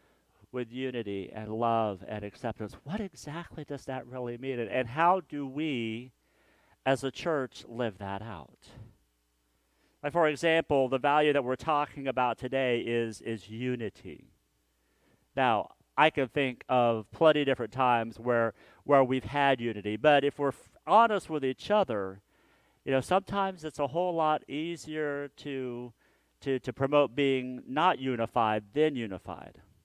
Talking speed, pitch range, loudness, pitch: 150 wpm, 115-145 Hz, -30 LUFS, 130 Hz